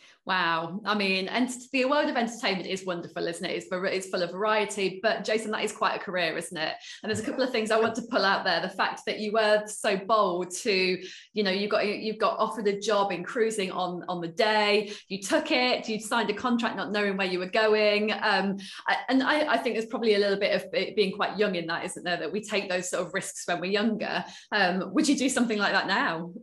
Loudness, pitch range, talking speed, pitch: -27 LUFS, 185-220 Hz, 250 wpm, 210 Hz